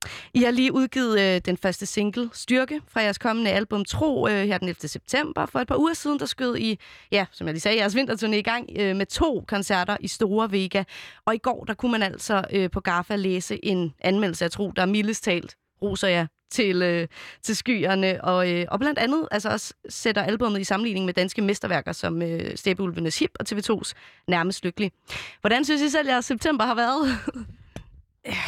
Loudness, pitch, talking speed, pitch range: -24 LUFS, 205 Hz, 205 wpm, 185-240 Hz